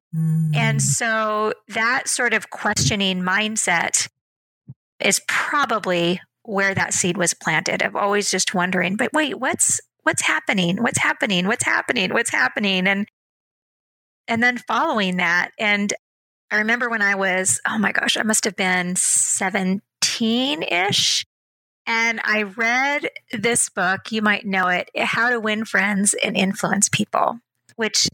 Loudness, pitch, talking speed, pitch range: -19 LUFS, 205 Hz, 140 wpm, 185-225 Hz